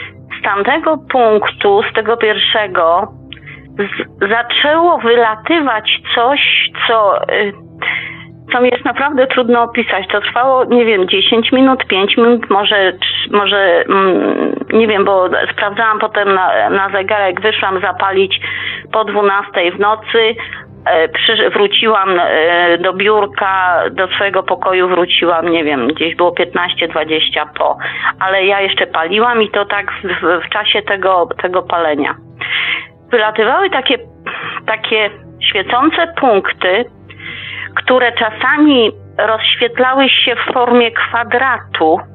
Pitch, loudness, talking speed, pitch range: 210 Hz, -12 LUFS, 115 wpm, 190-240 Hz